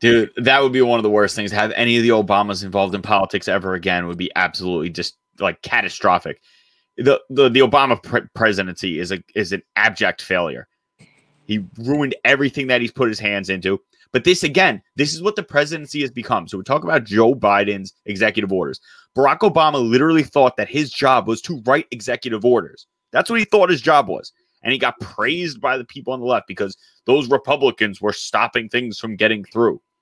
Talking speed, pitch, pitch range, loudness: 205 wpm, 120 Hz, 105-145 Hz, -18 LUFS